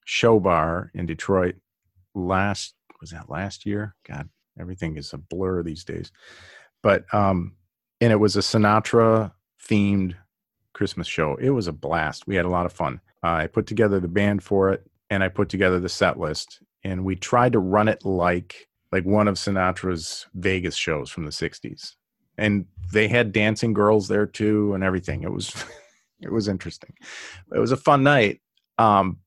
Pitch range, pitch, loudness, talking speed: 90-105 Hz, 95 Hz, -23 LUFS, 180 wpm